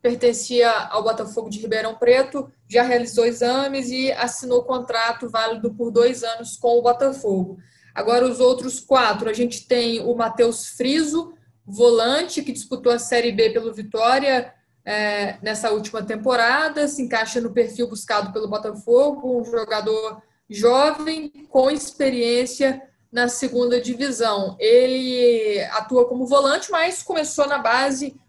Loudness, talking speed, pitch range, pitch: -20 LUFS, 135 wpm, 225-260 Hz, 240 Hz